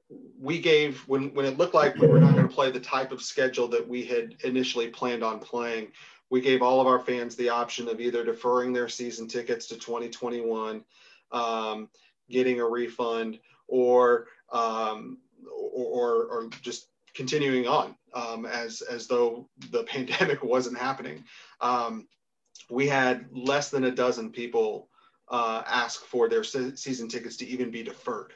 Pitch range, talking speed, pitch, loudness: 120-140 Hz, 165 wpm, 125 Hz, -27 LUFS